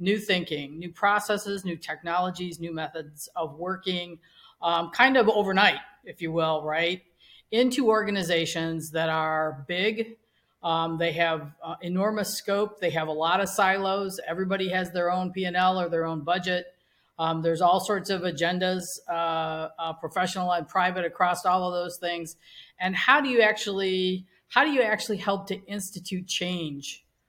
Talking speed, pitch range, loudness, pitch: 160 wpm, 165-195 Hz, -26 LUFS, 180 Hz